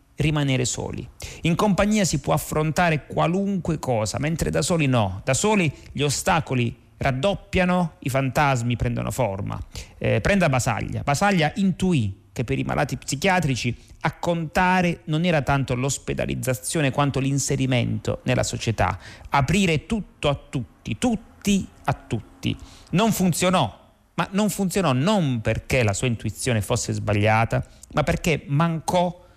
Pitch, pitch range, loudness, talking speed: 140 Hz, 120-175 Hz, -23 LUFS, 130 wpm